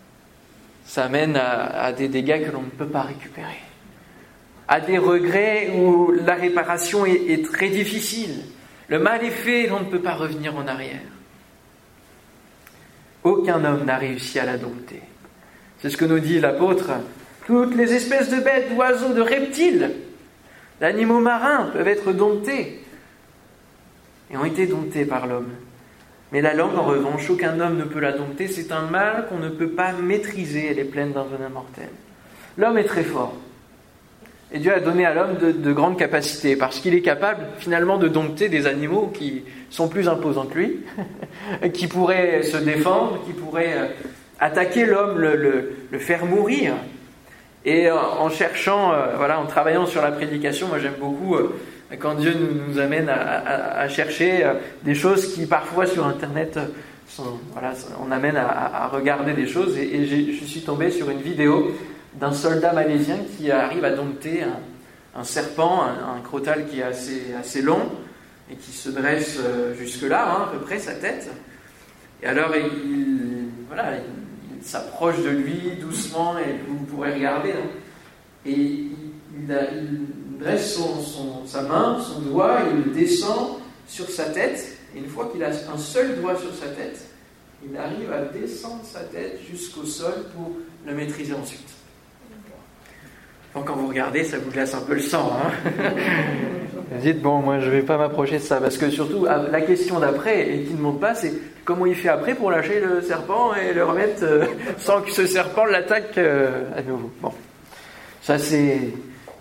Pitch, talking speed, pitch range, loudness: 155 Hz, 175 wpm, 140-185 Hz, -22 LUFS